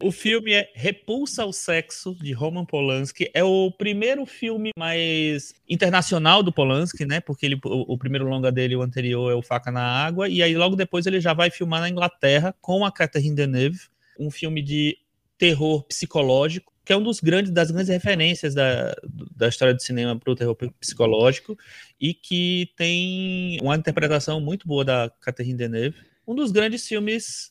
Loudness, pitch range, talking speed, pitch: -22 LUFS, 135-185 Hz, 180 wpm, 165 Hz